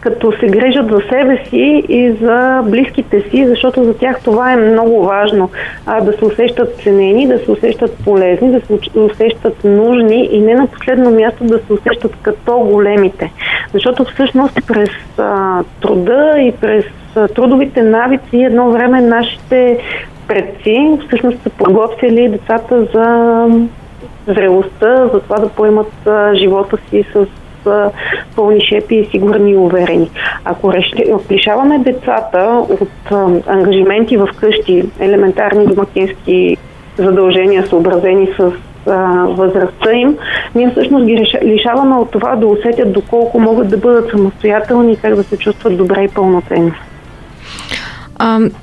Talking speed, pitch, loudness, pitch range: 135 wpm, 220 Hz, -11 LUFS, 200-240 Hz